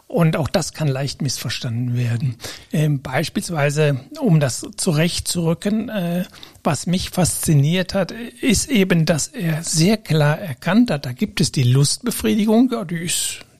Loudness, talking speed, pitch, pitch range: -19 LUFS, 135 wpm, 165 Hz, 145-195 Hz